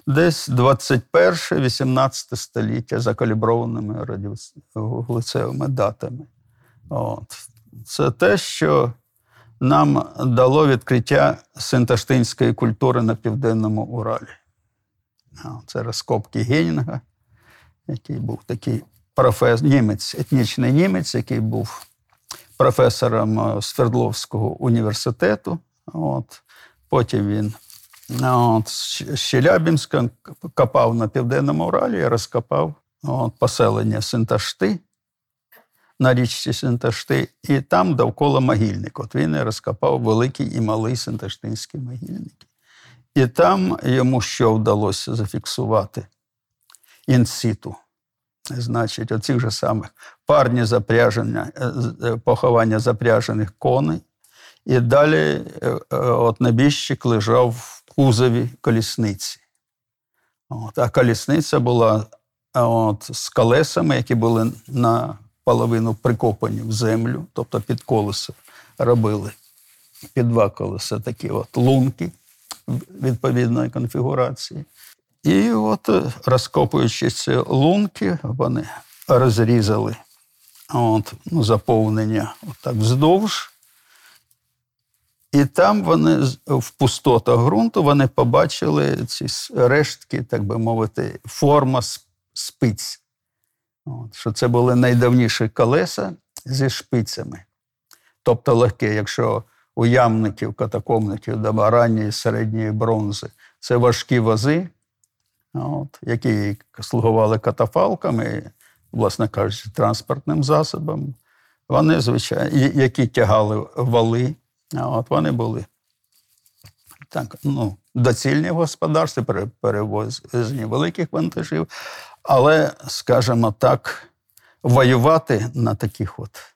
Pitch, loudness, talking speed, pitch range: 120 Hz, -19 LUFS, 90 wpm, 110-130 Hz